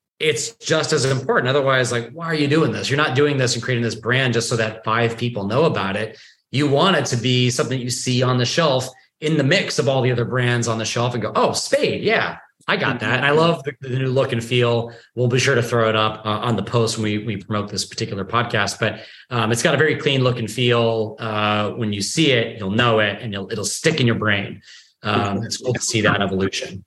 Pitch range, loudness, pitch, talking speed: 110-135 Hz, -19 LUFS, 120 Hz, 255 wpm